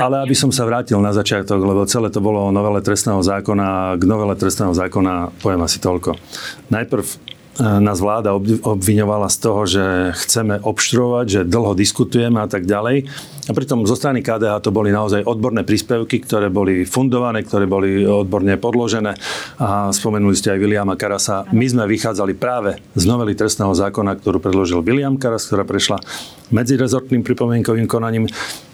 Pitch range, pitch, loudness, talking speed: 100-120 Hz, 105 Hz, -17 LUFS, 165 wpm